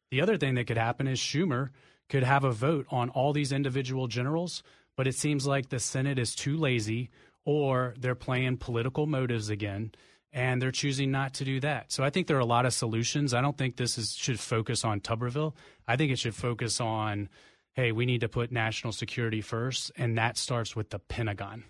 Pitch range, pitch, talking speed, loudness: 115-140 Hz, 125 Hz, 215 wpm, -30 LUFS